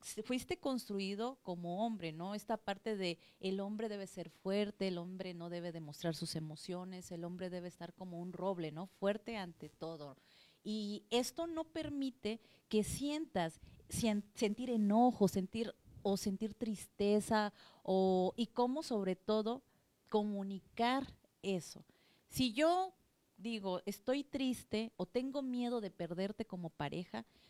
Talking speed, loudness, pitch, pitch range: 135 wpm, -40 LUFS, 200 Hz, 180-230 Hz